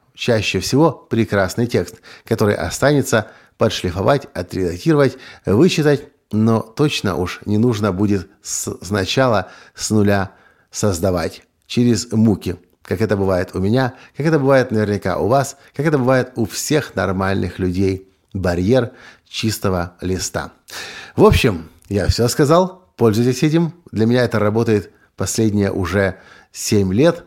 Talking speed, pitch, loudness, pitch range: 125 wpm, 110 Hz, -18 LUFS, 95-130 Hz